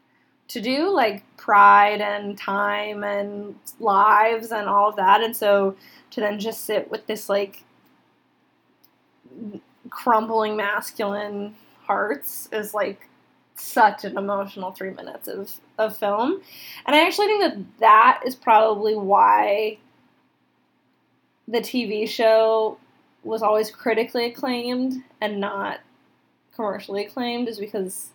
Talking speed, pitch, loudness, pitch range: 120 wpm, 215 Hz, -21 LUFS, 200-230 Hz